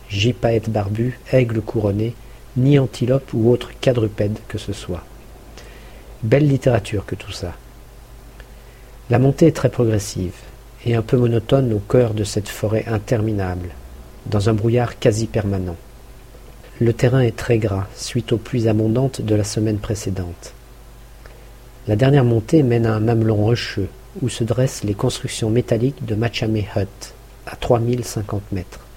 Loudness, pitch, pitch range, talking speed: -19 LUFS, 115 Hz, 105-125 Hz, 145 wpm